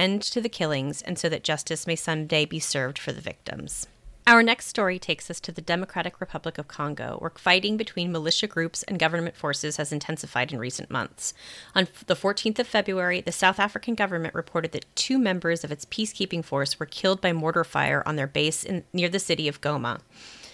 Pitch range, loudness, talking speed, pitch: 155-190 Hz, -26 LUFS, 205 wpm, 170 Hz